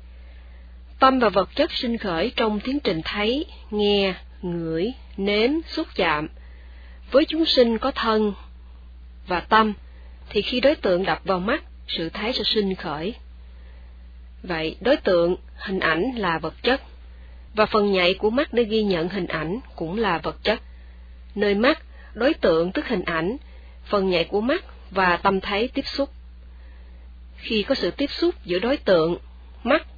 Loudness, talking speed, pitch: -23 LUFS, 160 wpm, 180 Hz